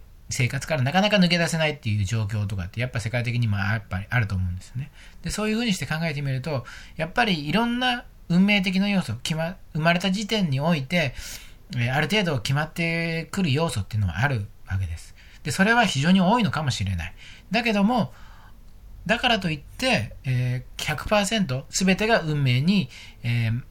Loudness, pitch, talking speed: -24 LUFS, 145 Hz, 390 characters per minute